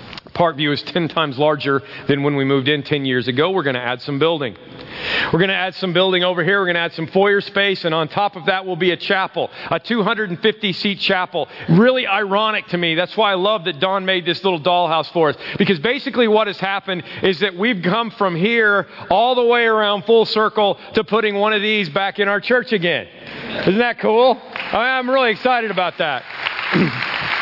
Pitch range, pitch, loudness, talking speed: 170-215 Hz, 195 Hz, -17 LUFS, 215 wpm